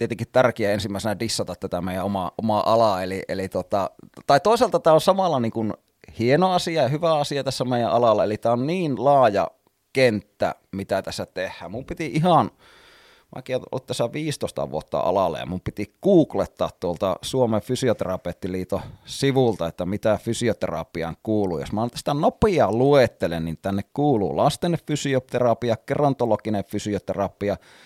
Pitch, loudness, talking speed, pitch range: 120 Hz, -23 LUFS, 145 wpm, 100-145 Hz